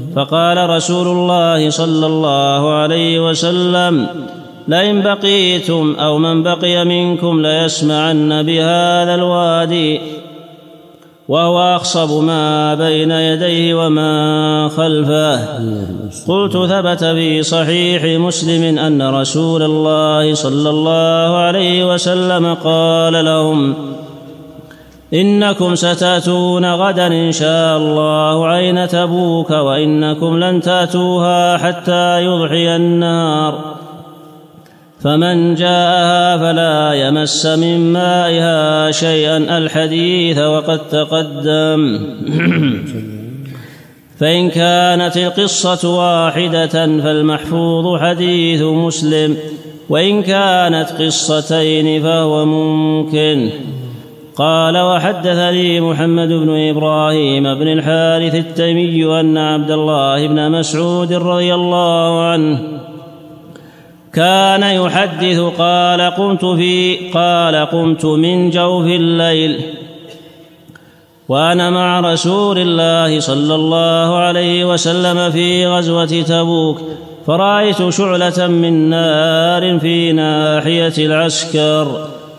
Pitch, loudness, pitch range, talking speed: 165 Hz, -12 LUFS, 155-175 Hz, 85 wpm